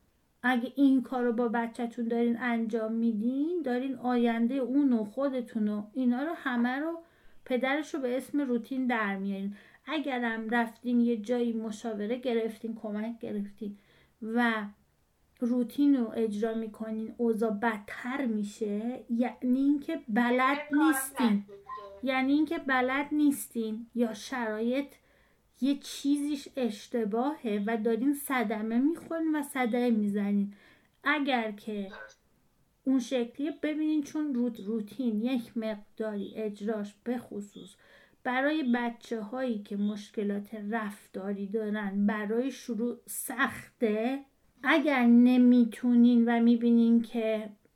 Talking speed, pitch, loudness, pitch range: 115 wpm, 240 Hz, -30 LUFS, 220-260 Hz